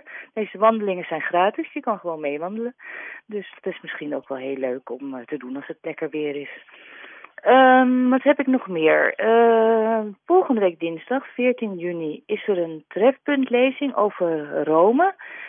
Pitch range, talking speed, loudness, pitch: 160-255 Hz, 165 wpm, -21 LUFS, 205 Hz